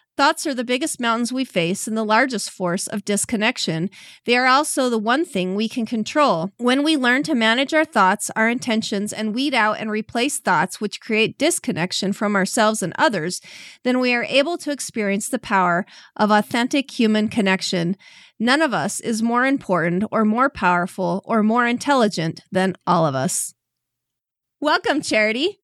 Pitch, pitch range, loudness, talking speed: 225 Hz, 195-255 Hz, -20 LUFS, 175 wpm